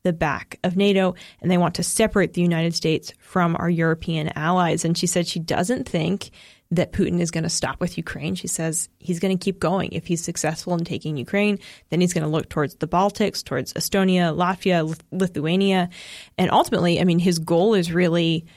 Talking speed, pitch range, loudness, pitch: 205 wpm, 165-185 Hz, -22 LUFS, 175 Hz